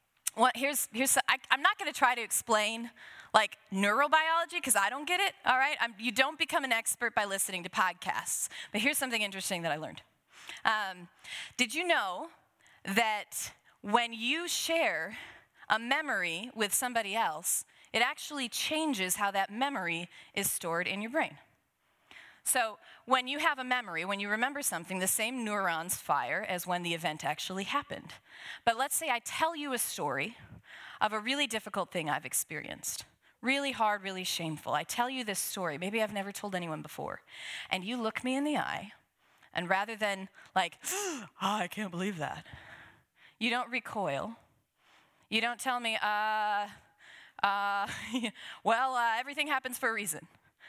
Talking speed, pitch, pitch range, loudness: 170 wpm, 225 Hz, 195-265 Hz, -32 LUFS